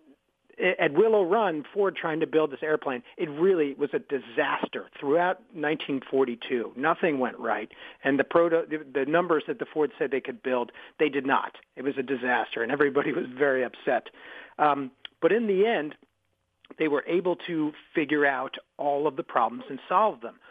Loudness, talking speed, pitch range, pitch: -27 LUFS, 180 wpm, 135-170 Hz, 150 Hz